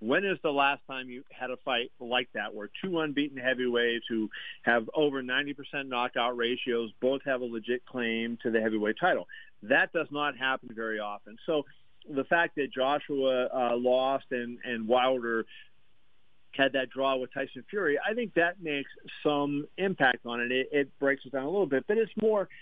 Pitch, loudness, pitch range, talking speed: 130 Hz, -30 LUFS, 120-145 Hz, 190 wpm